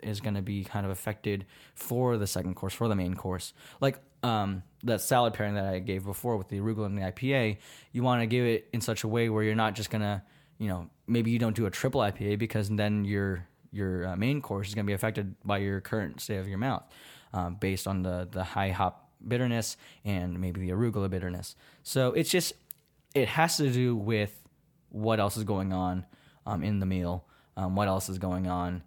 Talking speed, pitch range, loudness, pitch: 225 wpm, 95-115 Hz, -31 LUFS, 105 Hz